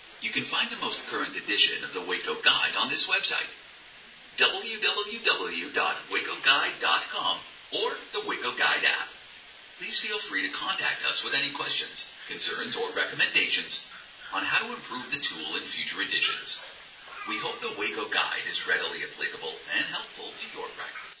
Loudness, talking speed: -26 LUFS, 155 wpm